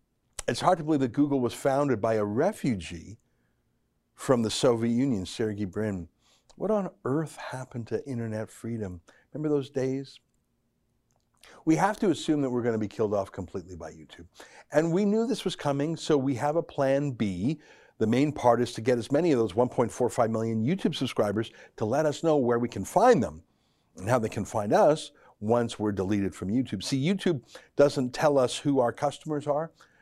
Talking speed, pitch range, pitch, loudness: 190 wpm, 110-145 Hz, 125 Hz, -27 LUFS